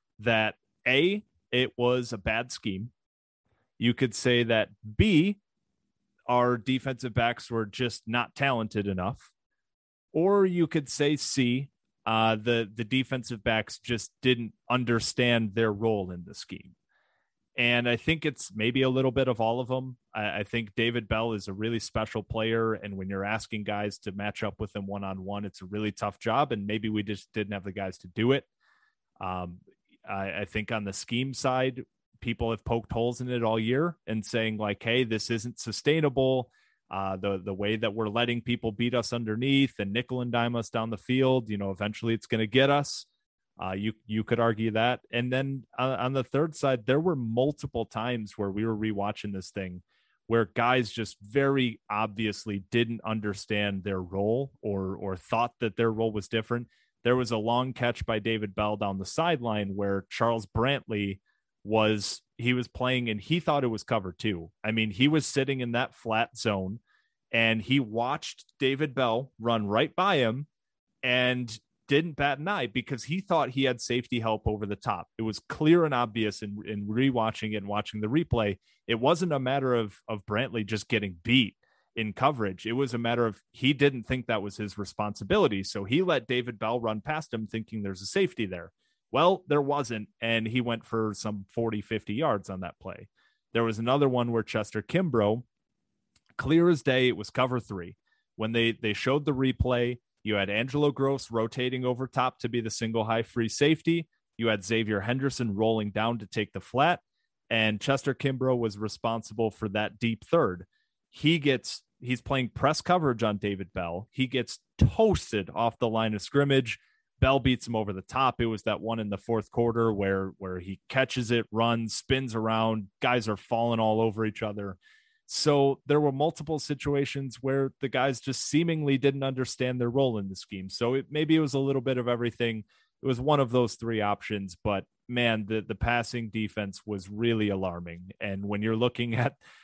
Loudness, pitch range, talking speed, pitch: -28 LUFS, 105-130 Hz, 190 wpm, 115 Hz